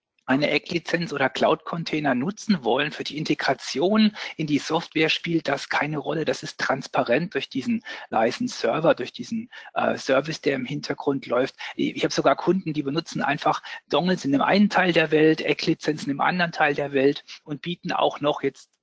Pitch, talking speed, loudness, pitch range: 155 Hz, 175 wpm, -24 LUFS, 145-180 Hz